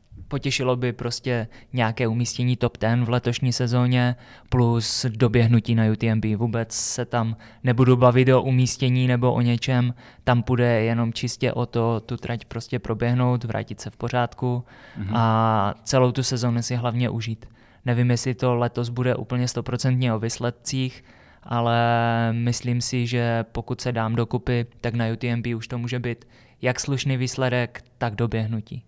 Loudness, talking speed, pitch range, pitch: -23 LUFS, 155 wpm, 115-125 Hz, 120 Hz